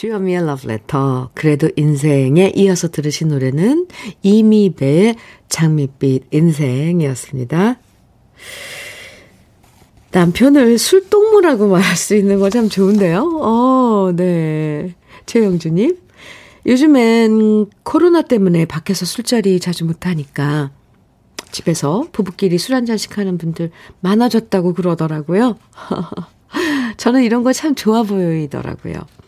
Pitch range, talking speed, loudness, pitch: 160-235 Hz, 255 characters per minute, -14 LUFS, 190 Hz